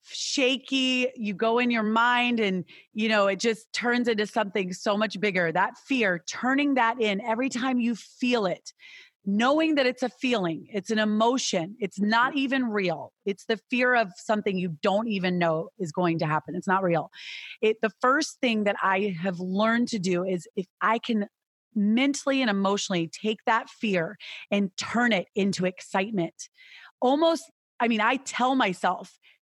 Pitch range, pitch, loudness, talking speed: 195-250 Hz, 220 Hz, -26 LUFS, 175 wpm